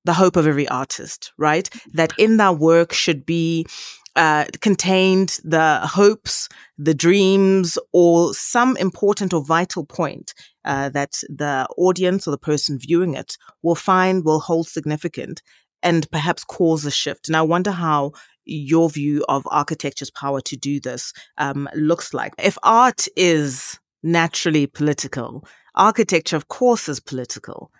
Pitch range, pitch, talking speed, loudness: 145-185 Hz, 165 Hz, 145 wpm, -19 LUFS